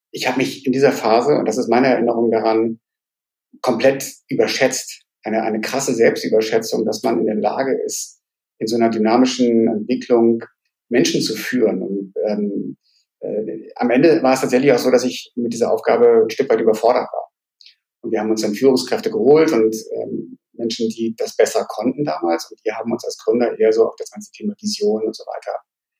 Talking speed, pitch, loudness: 190 wpm, 125 Hz, -18 LUFS